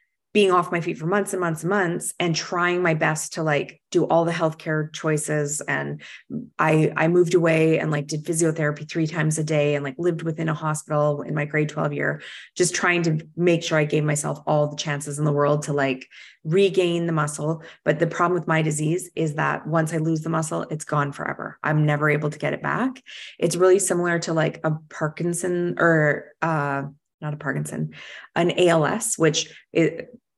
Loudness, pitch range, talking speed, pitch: -23 LUFS, 150-175 Hz, 205 wpm, 160 Hz